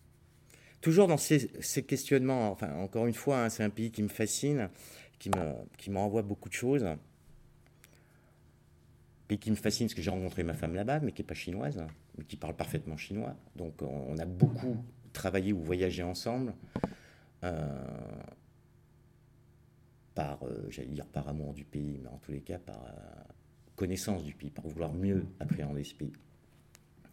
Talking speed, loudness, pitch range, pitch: 175 wpm, -34 LUFS, 80-115 Hz, 95 Hz